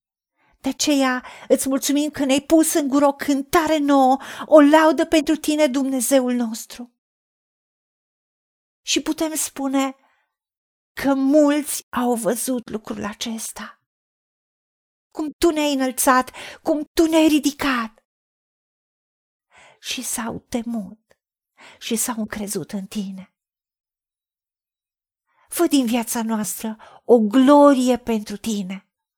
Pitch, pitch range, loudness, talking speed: 260 Hz, 220-290 Hz, -19 LUFS, 105 wpm